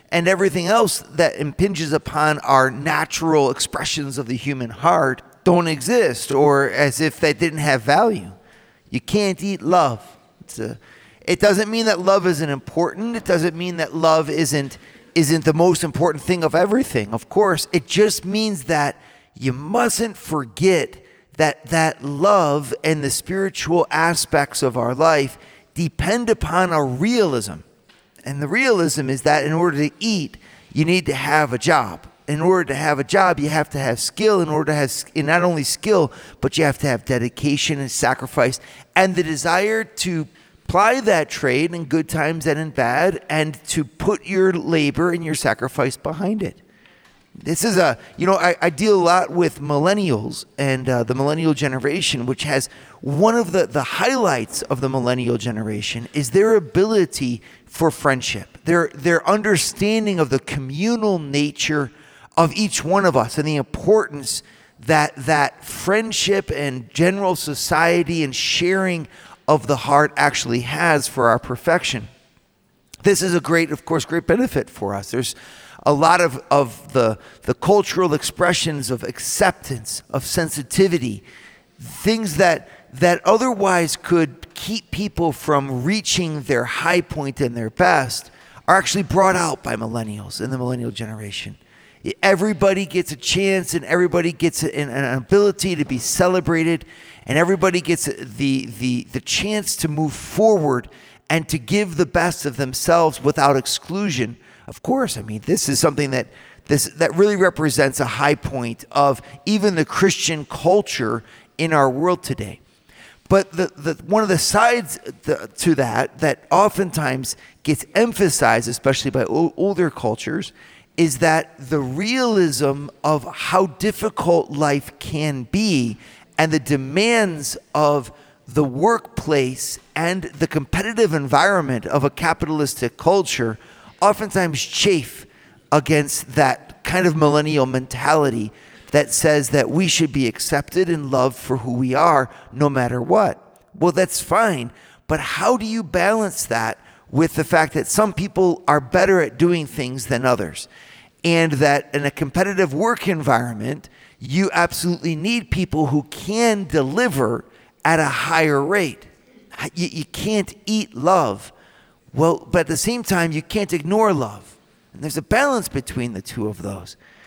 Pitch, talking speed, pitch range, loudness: 155 Hz, 155 wpm, 135-180 Hz, -19 LUFS